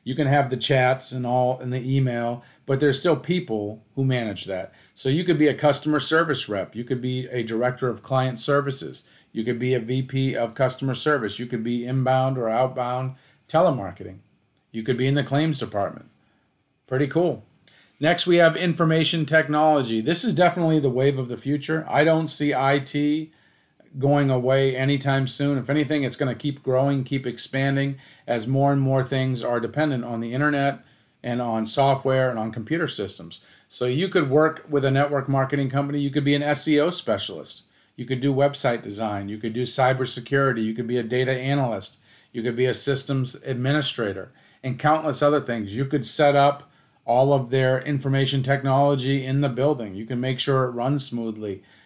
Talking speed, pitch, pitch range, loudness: 190 wpm, 135 Hz, 125-145 Hz, -23 LUFS